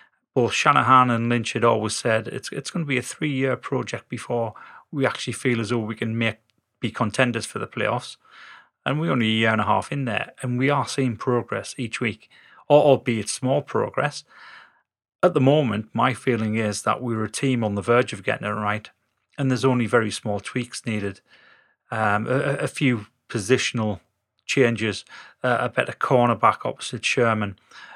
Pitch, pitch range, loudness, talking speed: 120 Hz, 110-130 Hz, -23 LUFS, 180 wpm